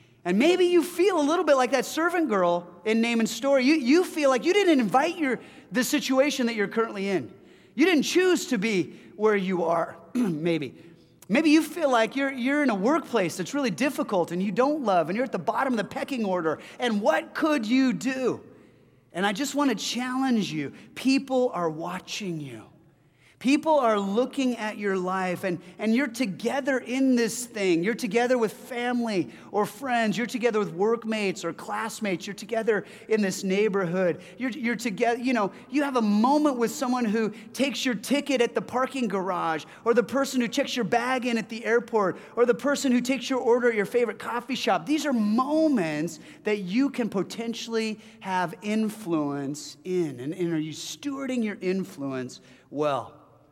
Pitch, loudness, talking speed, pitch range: 230 Hz, -26 LUFS, 190 wpm, 190-260 Hz